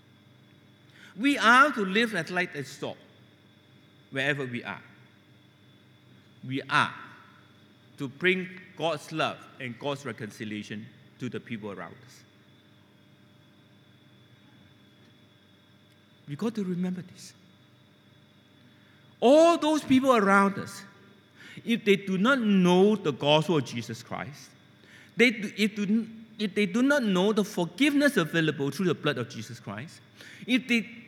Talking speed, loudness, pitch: 125 wpm, -26 LUFS, 150 Hz